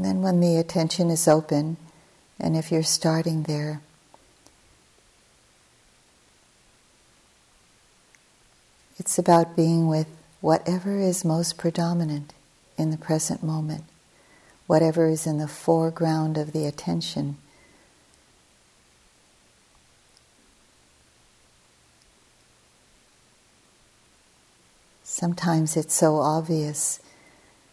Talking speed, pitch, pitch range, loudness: 80 wpm, 155 Hz, 145-165 Hz, -24 LUFS